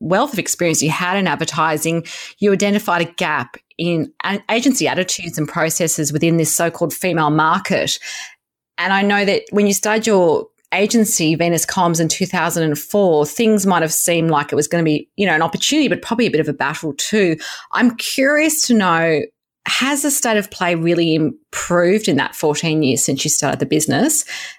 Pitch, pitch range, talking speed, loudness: 175 Hz, 160-210 Hz, 195 wpm, -16 LUFS